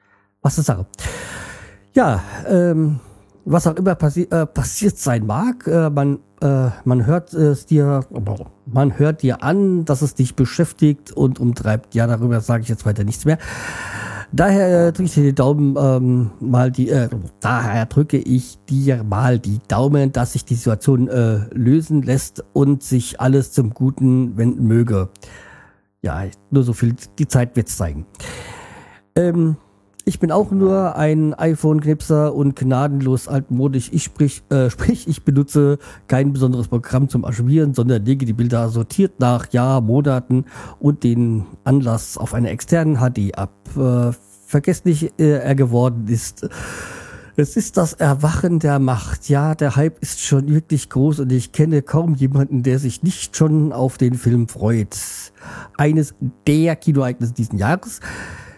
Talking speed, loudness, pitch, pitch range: 155 wpm, -18 LUFS, 130 Hz, 120-150 Hz